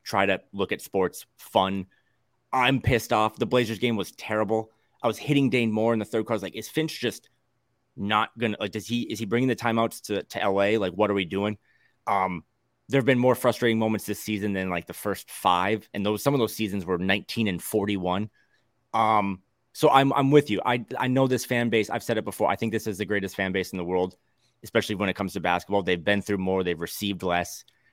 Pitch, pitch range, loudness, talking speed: 110 Hz, 100-120 Hz, -26 LUFS, 240 wpm